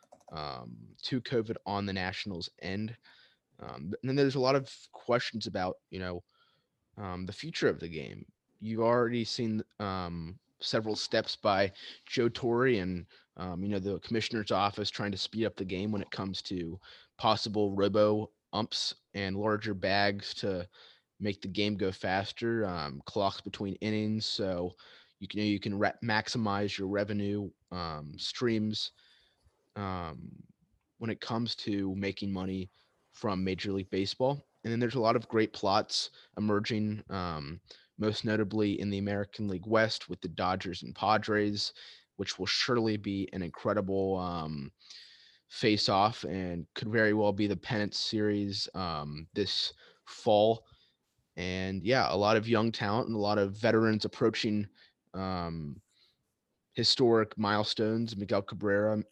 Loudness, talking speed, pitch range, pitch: -32 LUFS, 150 wpm, 95-110 Hz, 105 Hz